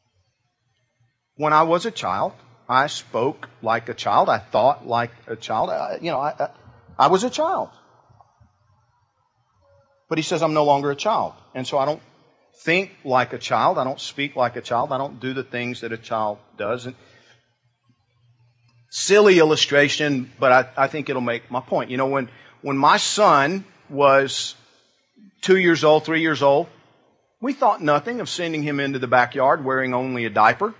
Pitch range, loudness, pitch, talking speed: 120-155 Hz, -20 LUFS, 135 Hz, 180 wpm